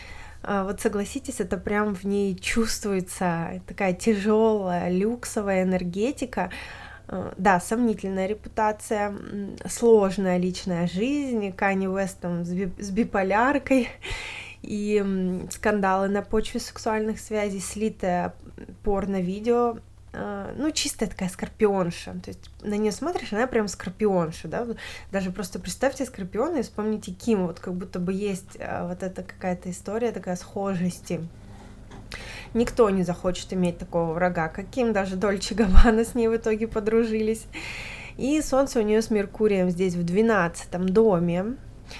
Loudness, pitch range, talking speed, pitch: -26 LUFS, 185-225 Hz, 120 wpm, 205 Hz